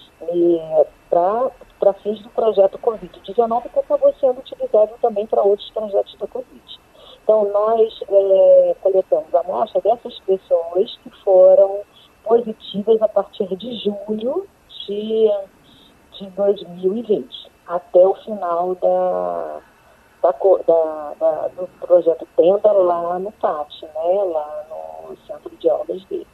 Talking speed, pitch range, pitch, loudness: 120 wpm, 180-245 Hz, 205 Hz, -18 LUFS